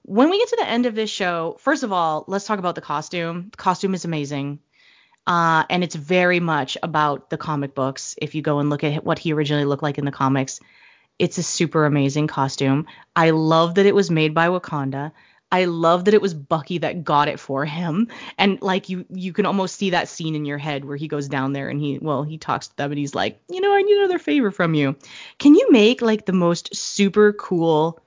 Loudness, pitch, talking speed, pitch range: -20 LUFS, 165 Hz, 235 wpm, 145-195 Hz